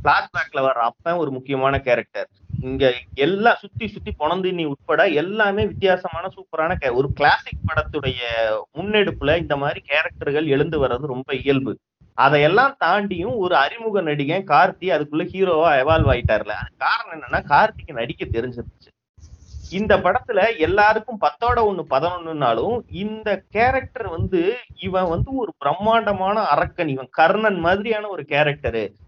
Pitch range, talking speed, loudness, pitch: 135-200 Hz, 125 wpm, -20 LUFS, 160 Hz